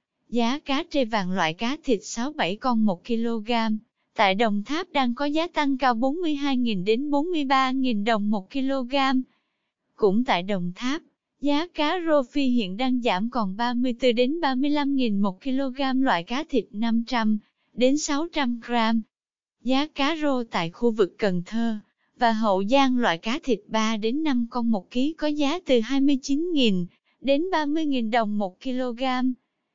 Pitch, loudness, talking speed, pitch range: 250 Hz, -24 LUFS, 155 wpm, 225-280 Hz